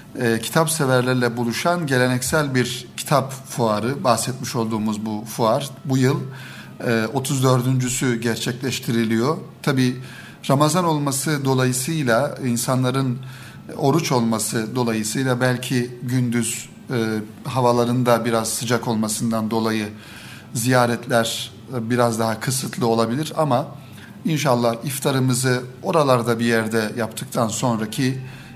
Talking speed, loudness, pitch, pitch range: 100 wpm, -21 LUFS, 125 Hz, 115-130 Hz